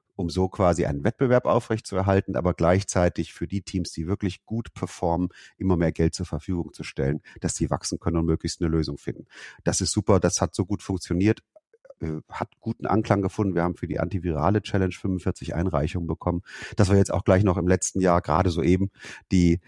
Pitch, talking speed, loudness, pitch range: 90 Hz, 195 wpm, -25 LUFS, 85-100 Hz